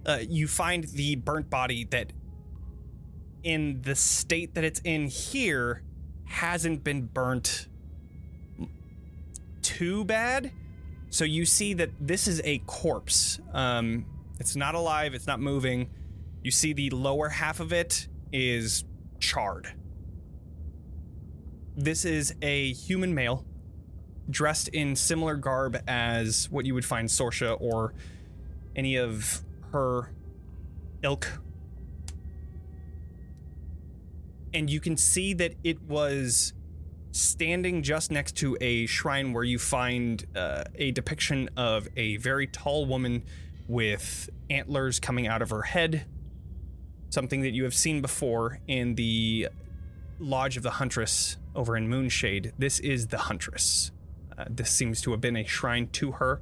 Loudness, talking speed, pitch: -28 LUFS, 130 wpm, 115 Hz